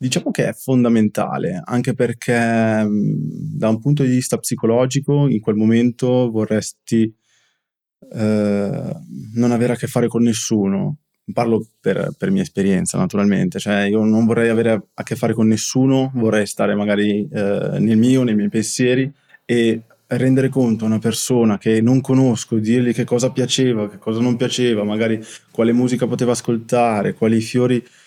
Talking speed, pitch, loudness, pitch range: 155 wpm, 115 Hz, -18 LUFS, 110-125 Hz